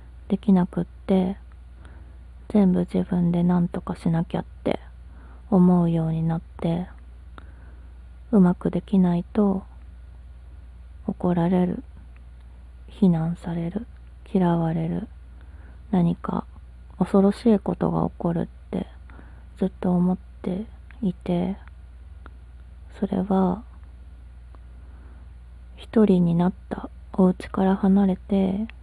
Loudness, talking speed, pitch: -23 LUFS, 180 characters per minute, 170 Hz